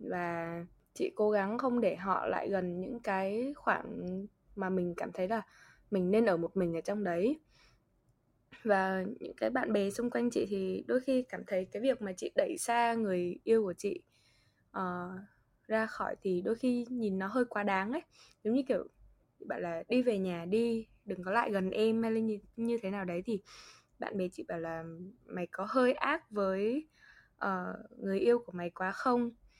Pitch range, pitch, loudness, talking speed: 185-235 Hz, 200 Hz, -34 LUFS, 200 wpm